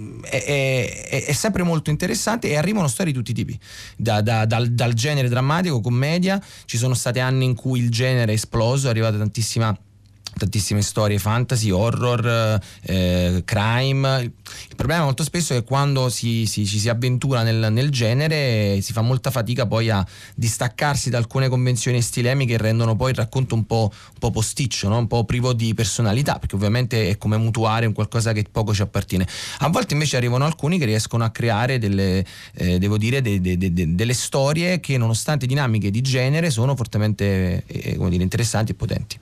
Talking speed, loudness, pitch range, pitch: 195 wpm, -21 LUFS, 105-130 Hz, 115 Hz